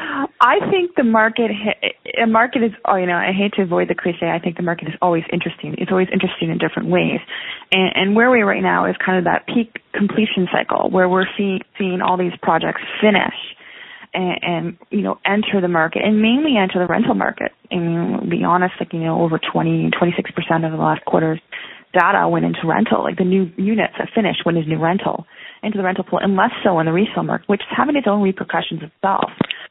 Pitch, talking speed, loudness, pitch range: 190 Hz, 220 wpm, -18 LUFS, 175-215 Hz